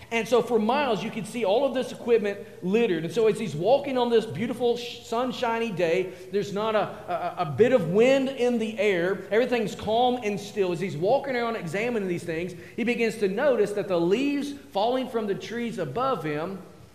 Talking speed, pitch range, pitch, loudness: 200 wpm, 190-240 Hz, 220 Hz, -26 LUFS